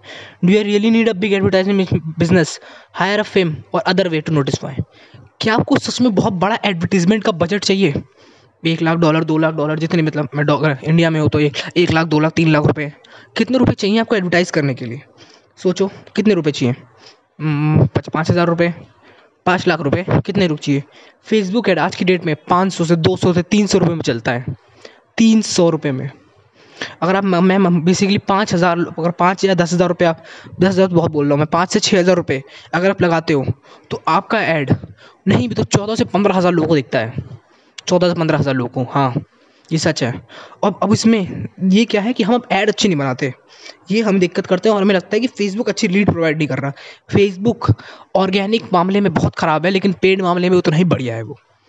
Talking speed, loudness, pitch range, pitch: 215 wpm, -16 LUFS, 150-195 Hz, 175 Hz